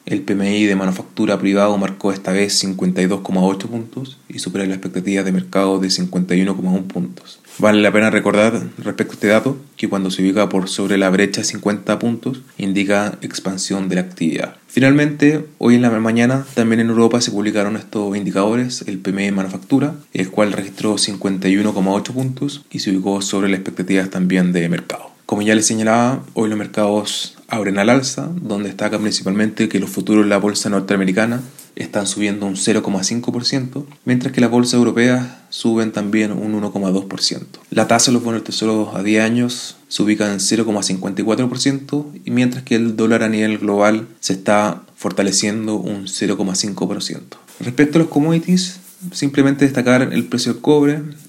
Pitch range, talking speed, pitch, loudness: 100-120 Hz, 165 wpm, 105 Hz, -17 LUFS